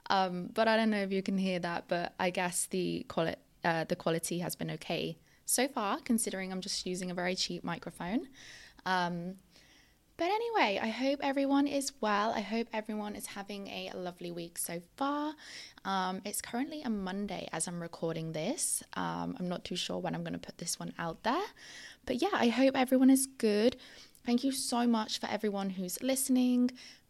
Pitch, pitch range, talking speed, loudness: 200 Hz, 175-250 Hz, 195 wpm, -33 LUFS